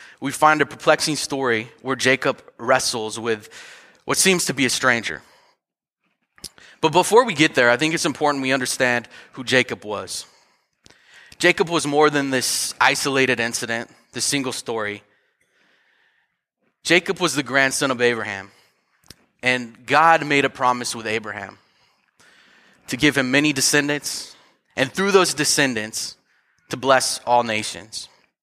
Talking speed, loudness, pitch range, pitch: 135 wpm, -19 LUFS, 115-150 Hz, 130 Hz